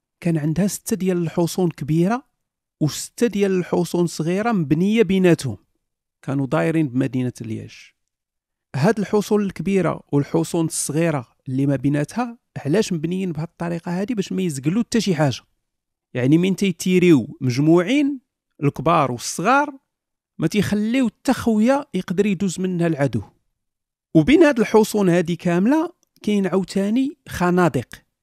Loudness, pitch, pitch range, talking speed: -20 LUFS, 175 Hz, 155-210 Hz, 115 wpm